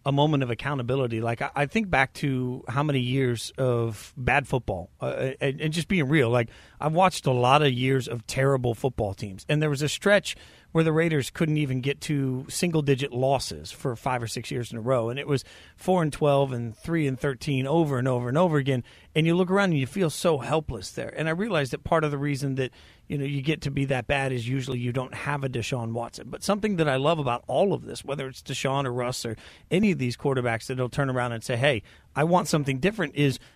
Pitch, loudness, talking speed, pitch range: 135 Hz, -26 LUFS, 245 wpm, 125-150 Hz